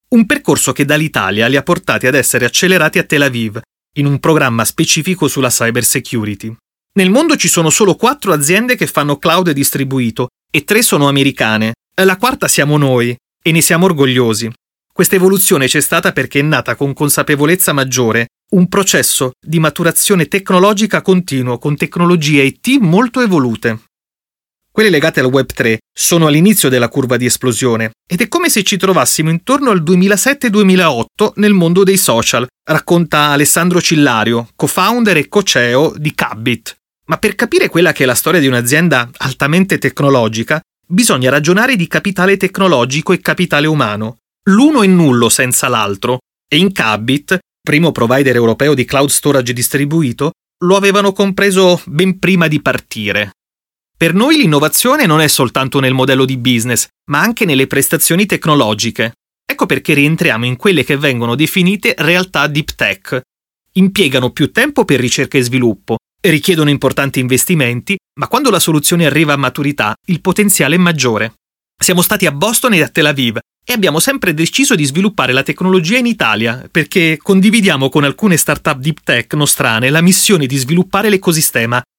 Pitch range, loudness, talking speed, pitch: 130-185 Hz, -11 LUFS, 160 wpm, 155 Hz